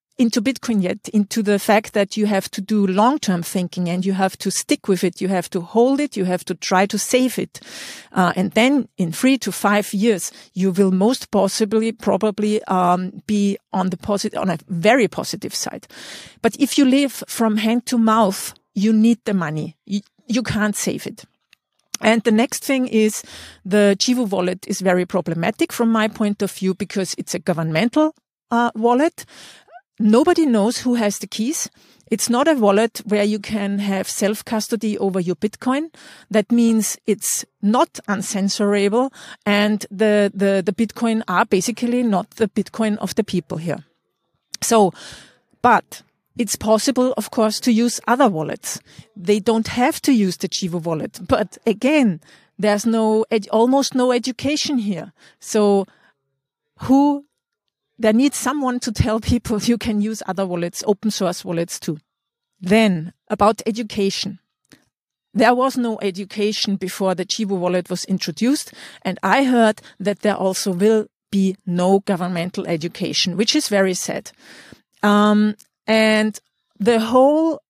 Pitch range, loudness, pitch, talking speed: 195-235 Hz, -19 LUFS, 210 Hz, 160 wpm